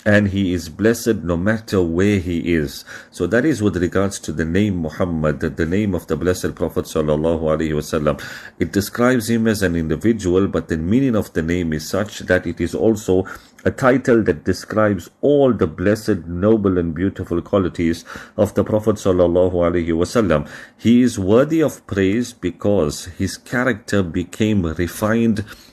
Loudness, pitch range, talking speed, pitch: -19 LUFS, 85-110 Hz, 170 wpm, 95 Hz